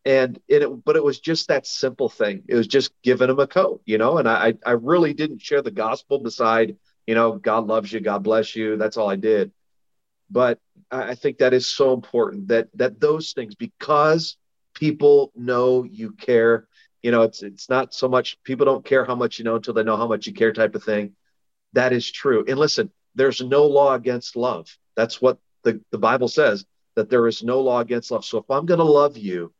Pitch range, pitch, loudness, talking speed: 115-150 Hz, 125 Hz, -20 LUFS, 220 wpm